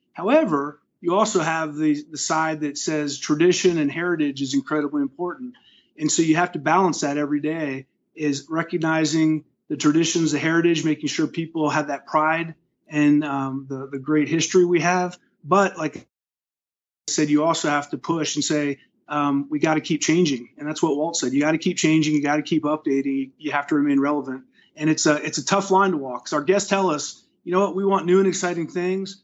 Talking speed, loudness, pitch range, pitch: 215 wpm, -22 LUFS, 145-175 Hz, 155 Hz